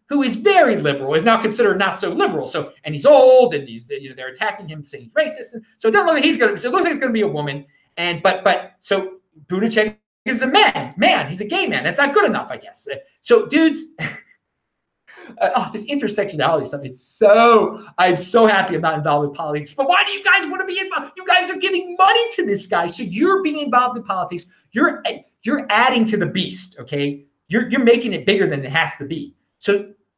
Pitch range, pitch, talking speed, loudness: 175-290 Hz, 215 Hz, 240 wpm, -17 LUFS